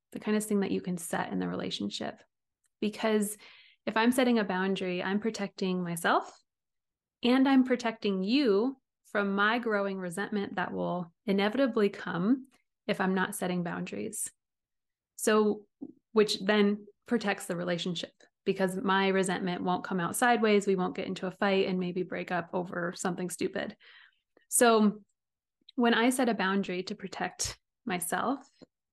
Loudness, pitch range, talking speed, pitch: -30 LUFS, 185-220 Hz, 150 wpm, 200 Hz